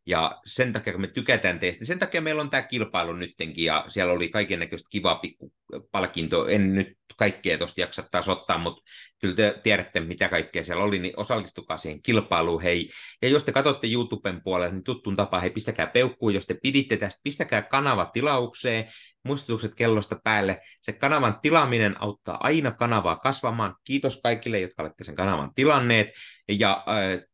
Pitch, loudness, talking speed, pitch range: 105 Hz, -25 LUFS, 175 wpm, 95-125 Hz